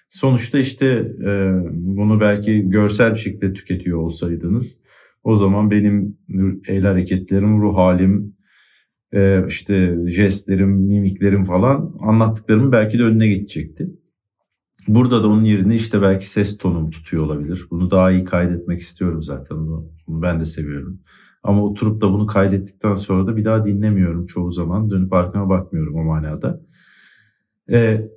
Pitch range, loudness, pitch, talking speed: 90-105 Hz, -17 LUFS, 100 Hz, 135 wpm